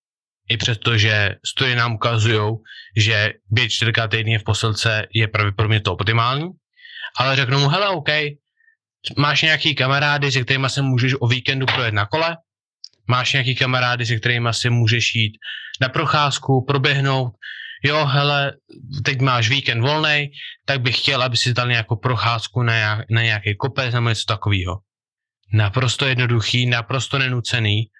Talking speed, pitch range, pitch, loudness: 150 wpm, 115-140 Hz, 125 Hz, -18 LUFS